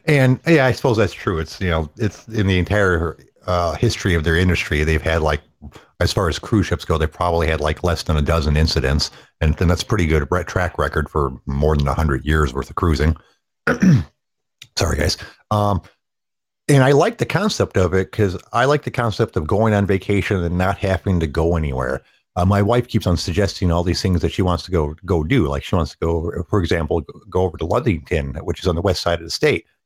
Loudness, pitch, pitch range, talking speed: -19 LUFS, 90 Hz, 80-100 Hz, 230 wpm